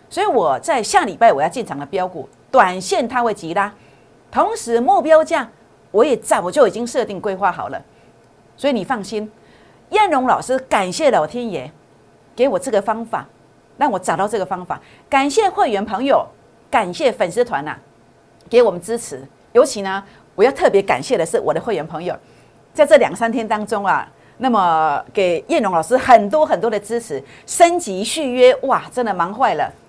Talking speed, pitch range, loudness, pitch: 265 characters per minute, 210-310 Hz, -17 LUFS, 245 Hz